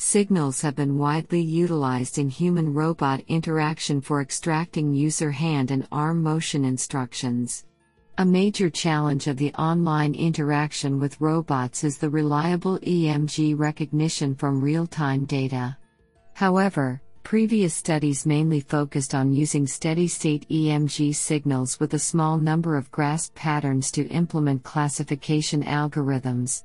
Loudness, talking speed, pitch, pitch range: -24 LUFS, 130 wpm, 150 Hz, 140-160 Hz